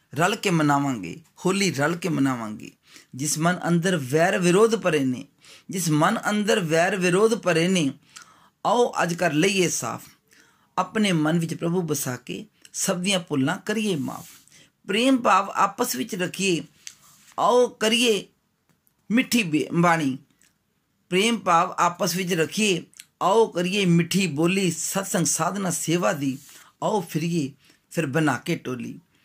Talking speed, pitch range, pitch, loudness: 135 wpm, 155-195 Hz, 175 Hz, -23 LUFS